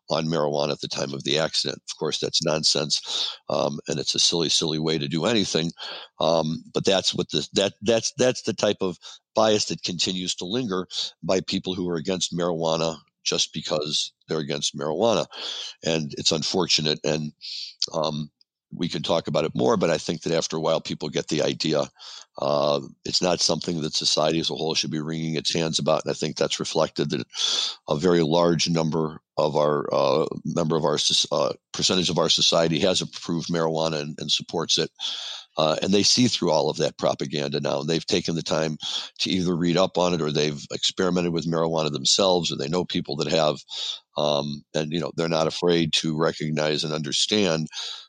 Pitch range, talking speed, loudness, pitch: 75-90 Hz, 195 wpm, -24 LUFS, 80 Hz